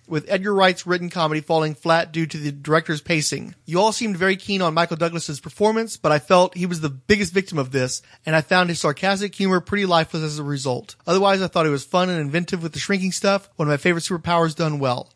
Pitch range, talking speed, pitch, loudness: 155-190 Hz, 240 wpm, 170 Hz, -21 LUFS